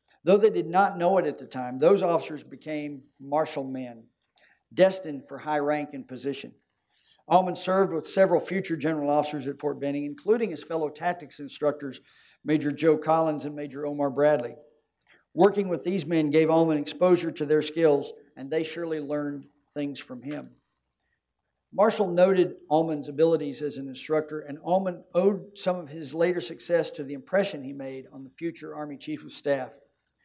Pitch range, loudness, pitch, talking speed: 145-170 Hz, -26 LUFS, 150 Hz, 170 wpm